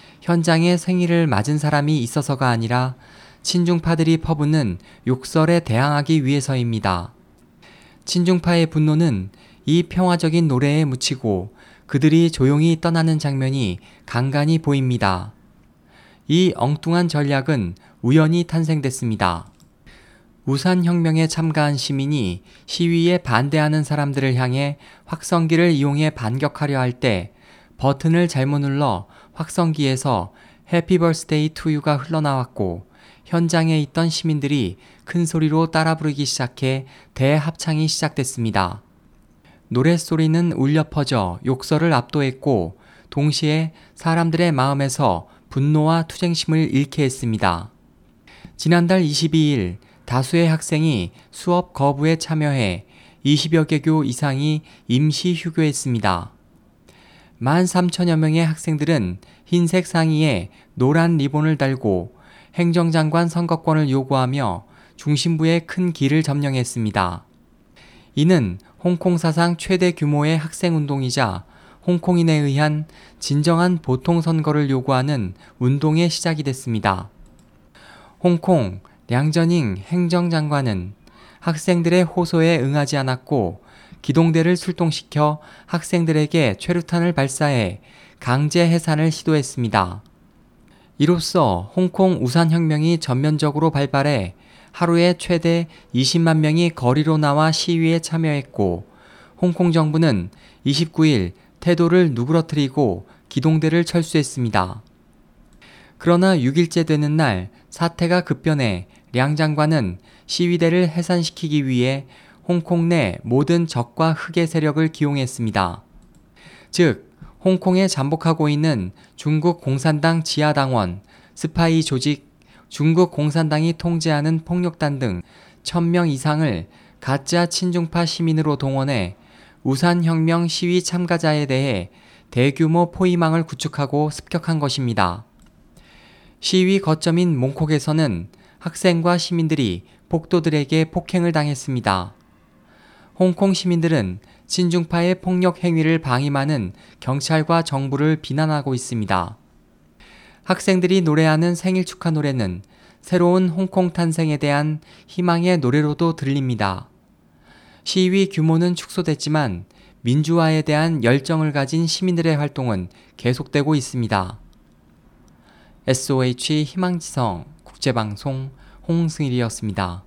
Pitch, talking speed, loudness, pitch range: 155 Hz, 265 characters per minute, -19 LUFS, 130-170 Hz